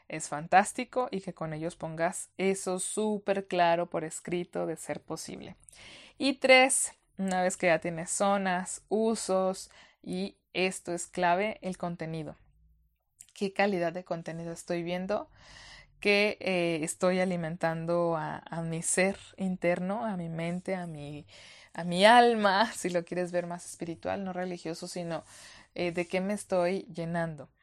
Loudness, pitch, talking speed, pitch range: -30 LUFS, 175 Hz, 150 wpm, 165-190 Hz